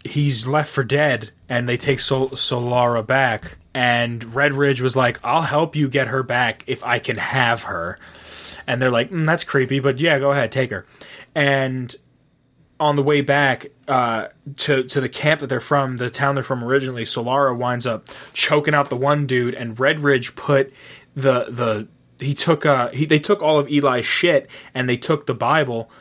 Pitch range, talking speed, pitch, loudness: 125-145 Hz, 190 wpm, 135 Hz, -19 LUFS